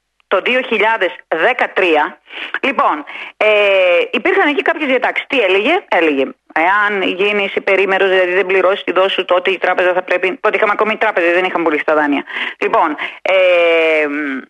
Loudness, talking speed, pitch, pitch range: -14 LUFS, 150 wpm, 190 Hz, 180-215 Hz